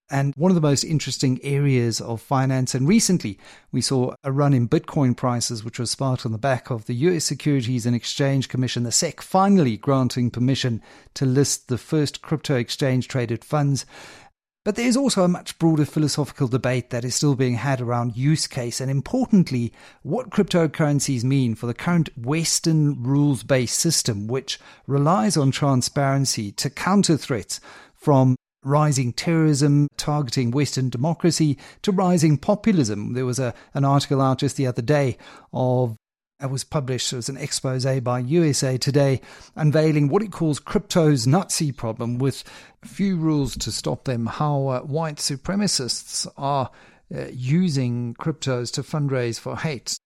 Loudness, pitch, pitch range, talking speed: -22 LUFS, 140 Hz, 125-155 Hz, 160 wpm